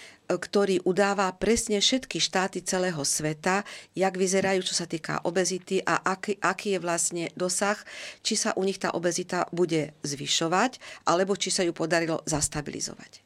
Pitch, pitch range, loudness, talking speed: 185 Hz, 170-195 Hz, -27 LUFS, 150 wpm